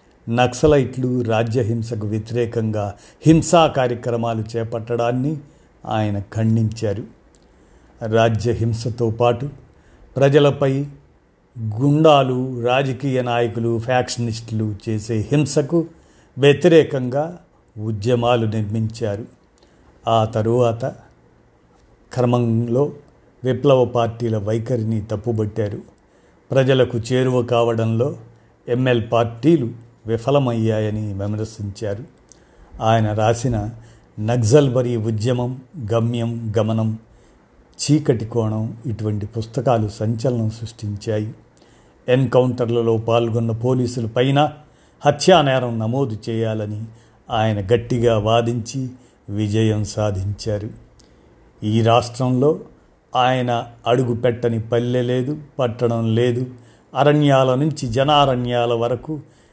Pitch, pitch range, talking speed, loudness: 120 Hz, 110-130 Hz, 70 wpm, -19 LUFS